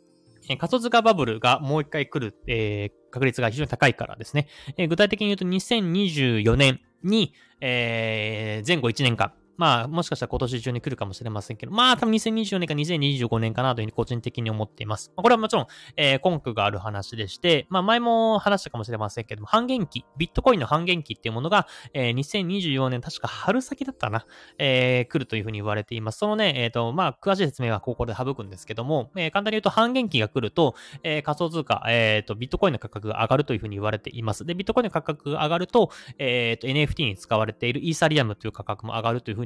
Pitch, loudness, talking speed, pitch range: 135 Hz, -24 LUFS, 460 characters per minute, 115-175 Hz